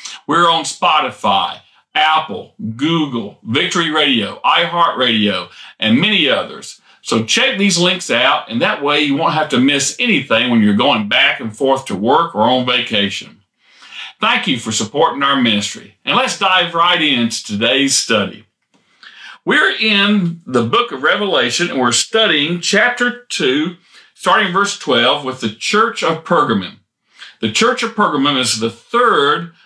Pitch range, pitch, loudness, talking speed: 125-200 Hz, 160 Hz, -14 LUFS, 155 wpm